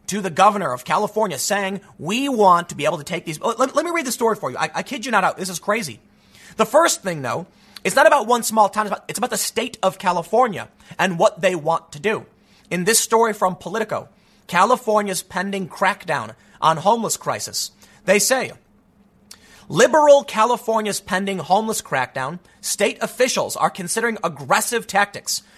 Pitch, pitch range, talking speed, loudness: 200 Hz, 180-225 Hz, 190 wpm, -19 LUFS